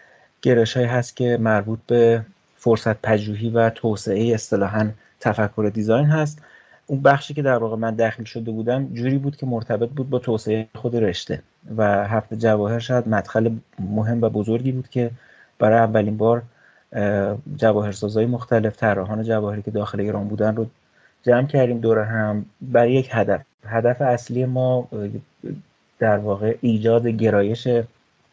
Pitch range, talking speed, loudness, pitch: 110-120 Hz, 145 wpm, -21 LUFS, 115 Hz